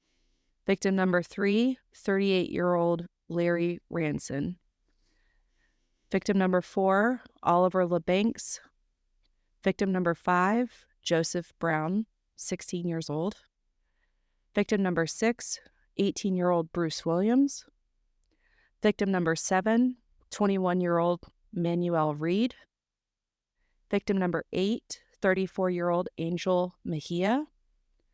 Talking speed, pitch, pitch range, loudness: 95 wpm, 185 Hz, 170-205 Hz, -29 LUFS